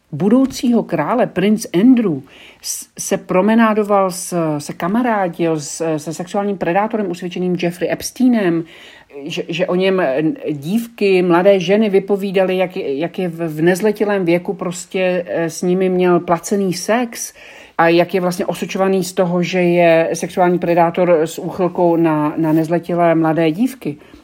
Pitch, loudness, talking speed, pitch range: 180 Hz, -16 LUFS, 135 wpm, 170-200 Hz